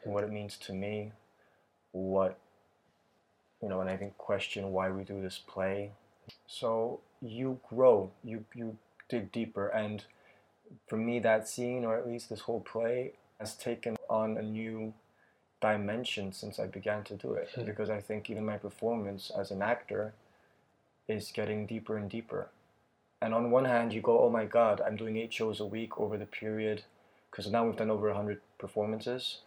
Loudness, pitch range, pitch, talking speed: -34 LUFS, 105-115 Hz, 110 Hz, 175 wpm